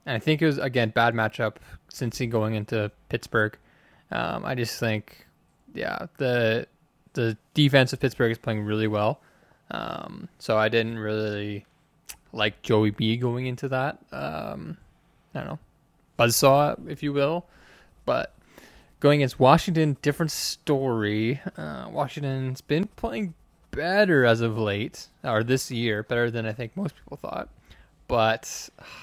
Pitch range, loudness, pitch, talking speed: 110-145 Hz, -25 LUFS, 120 Hz, 150 wpm